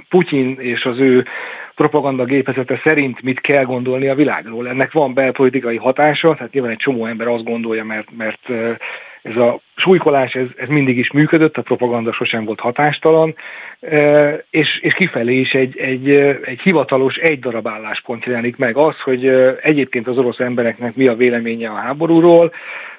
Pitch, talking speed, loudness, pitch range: 130 Hz, 160 wpm, -15 LUFS, 120-145 Hz